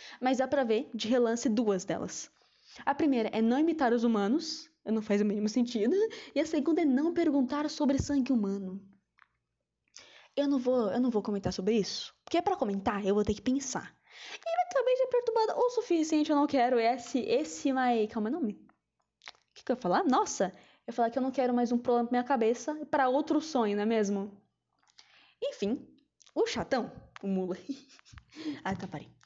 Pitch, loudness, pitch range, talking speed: 250 Hz, -30 LUFS, 215-300 Hz, 195 wpm